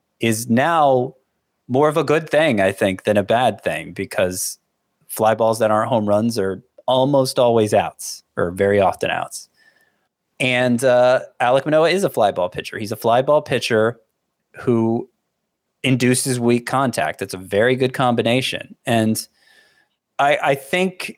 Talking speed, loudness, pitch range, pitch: 155 wpm, -18 LUFS, 110-135 Hz, 125 Hz